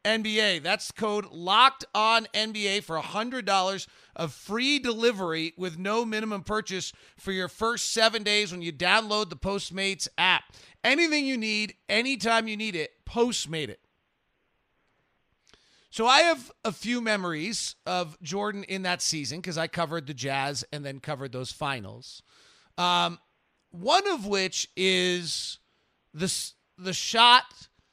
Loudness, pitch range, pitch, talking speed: -26 LUFS, 170-220 Hz, 195 Hz, 140 wpm